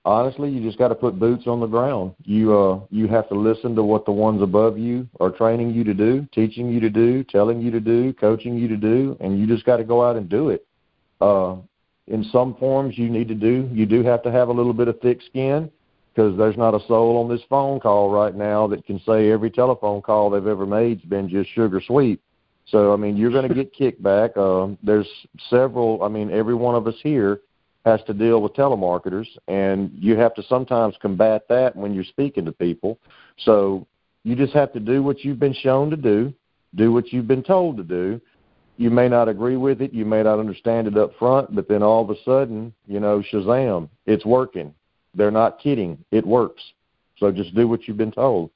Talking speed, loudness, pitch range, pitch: 225 wpm, -20 LUFS, 105-120 Hz, 115 Hz